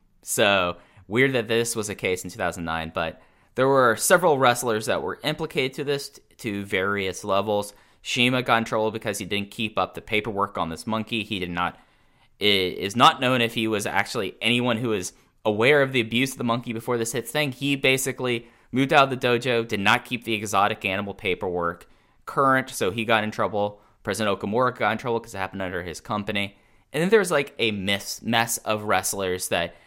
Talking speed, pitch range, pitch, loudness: 215 wpm, 100-125 Hz, 110 Hz, -24 LUFS